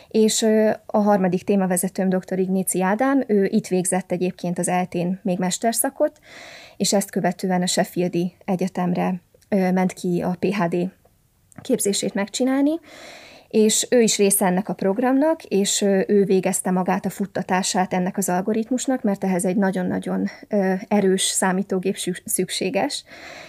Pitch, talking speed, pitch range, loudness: 195 Hz, 130 wpm, 185-215 Hz, -21 LUFS